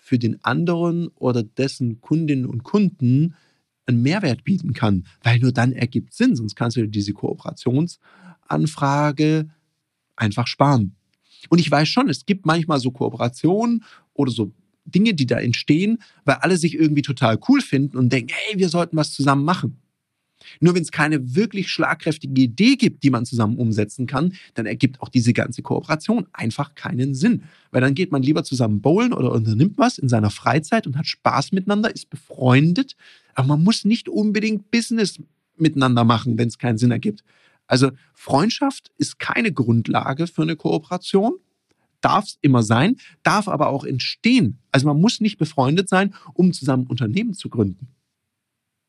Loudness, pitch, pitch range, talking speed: -20 LUFS, 145 Hz, 125-180 Hz, 165 wpm